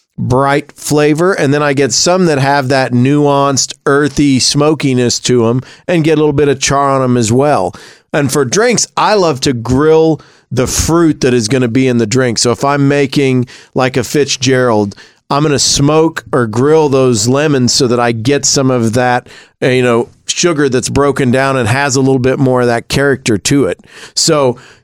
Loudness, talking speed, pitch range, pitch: -11 LUFS, 200 wpm, 125-145 Hz, 135 Hz